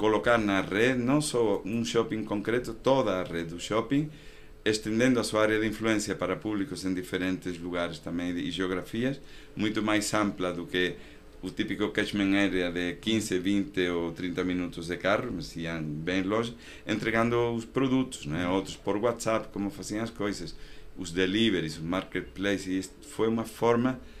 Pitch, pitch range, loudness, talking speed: 100 Hz, 90-115 Hz, -29 LUFS, 165 wpm